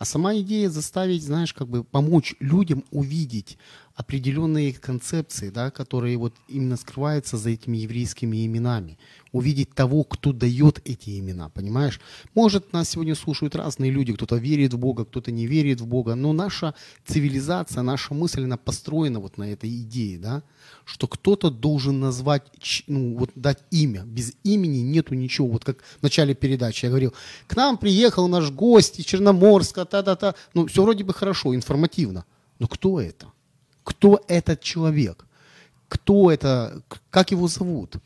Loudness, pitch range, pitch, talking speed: -22 LUFS, 125-165 Hz, 140 Hz, 160 wpm